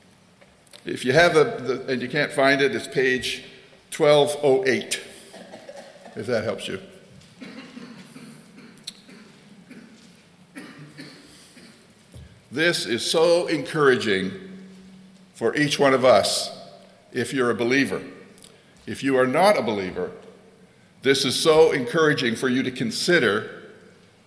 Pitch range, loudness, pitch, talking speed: 130-205 Hz, -21 LUFS, 155 Hz, 110 wpm